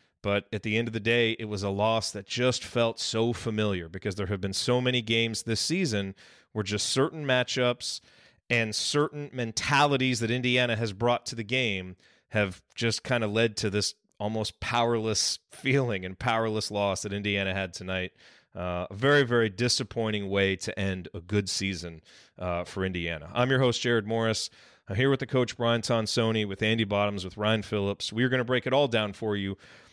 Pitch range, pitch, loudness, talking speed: 100-120 Hz, 110 Hz, -28 LUFS, 195 wpm